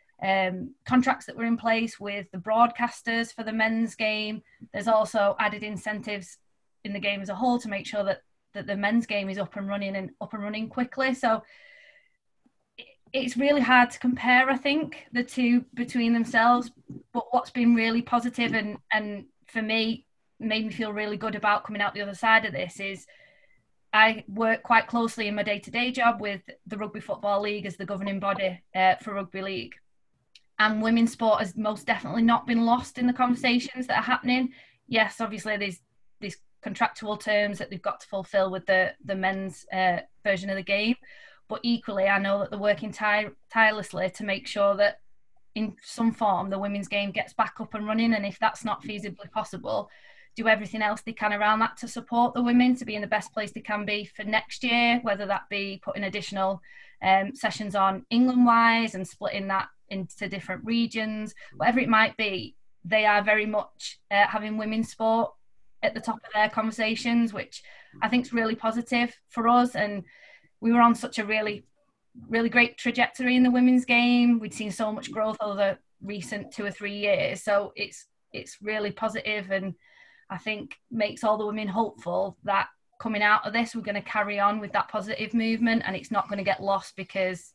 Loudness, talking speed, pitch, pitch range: -26 LUFS, 195 wpm, 215 Hz, 200-235 Hz